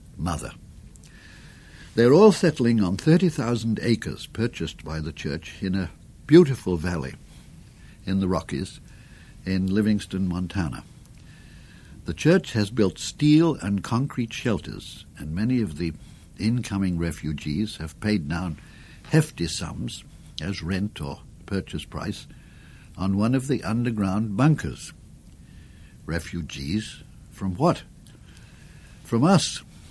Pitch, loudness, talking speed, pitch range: 100 Hz, -24 LUFS, 110 wpm, 85-120 Hz